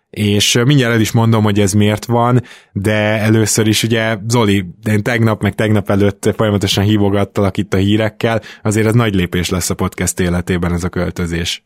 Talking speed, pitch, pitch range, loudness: 180 wpm, 105 Hz, 100-110 Hz, -14 LUFS